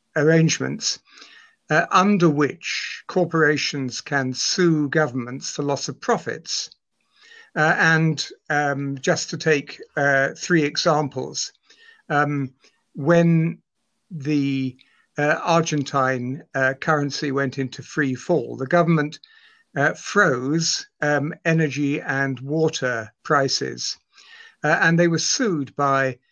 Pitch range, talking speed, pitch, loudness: 140-170 Hz, 105 wpm, 150 Hz, -21 LUFS